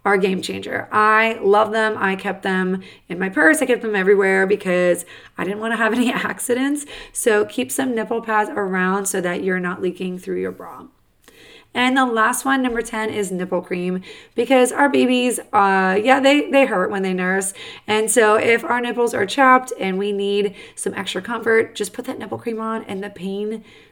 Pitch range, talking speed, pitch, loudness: 190-235 Hz, 200 wpm, 210 Hz, -19 LUFS